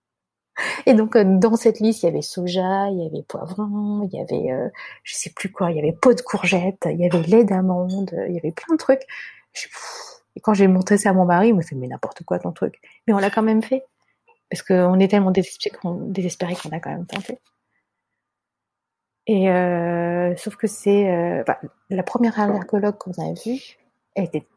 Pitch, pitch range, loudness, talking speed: 195 Hz, 175-220 Hz, -20 LUFS, 210 wpm